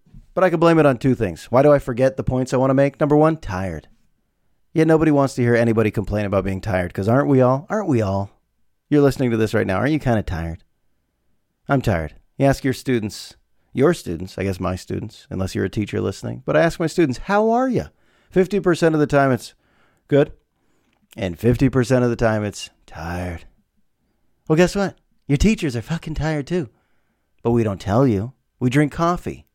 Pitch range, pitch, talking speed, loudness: 100-150 Hz, 125 Hz, 215 wpm, -20 LUFS